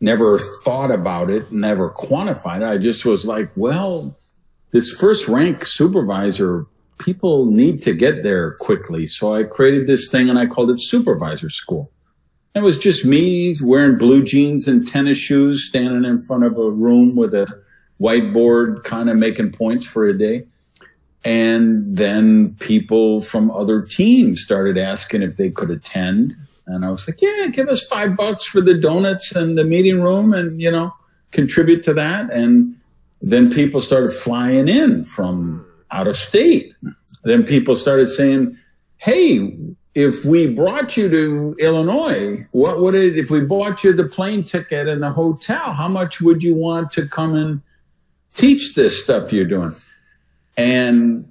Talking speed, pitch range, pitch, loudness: 165 wpm, 120-185 Hz, 145 Hz, -16 LUFS